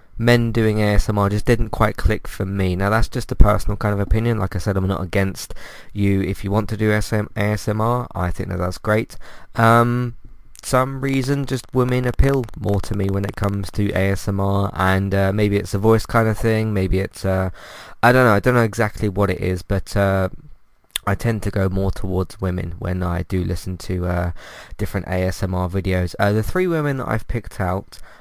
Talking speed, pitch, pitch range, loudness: 210 wpm, 100 Hz, 95-115 Hz, -20 LUFS